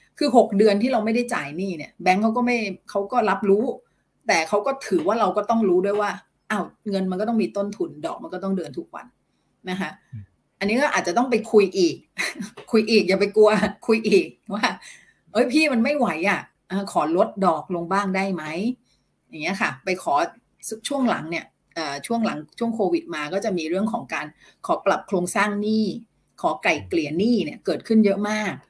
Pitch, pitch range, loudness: 205 Hz, 190-230 Hz, -22 LUFS